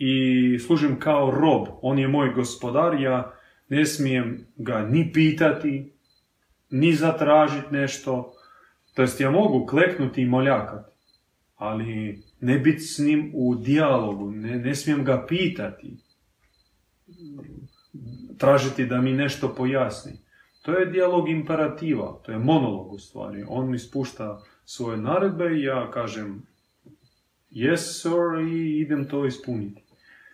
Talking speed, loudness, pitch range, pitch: 125 wpm, -23 LUFS, 125-150 Hz, 135 Hz